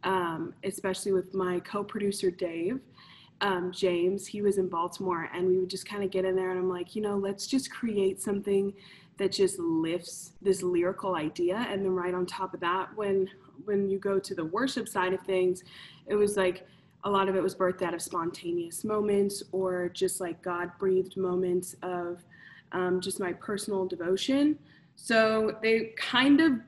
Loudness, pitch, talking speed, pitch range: -30 LUFS, 185 Hz, 185 wpm, 180-200 Hz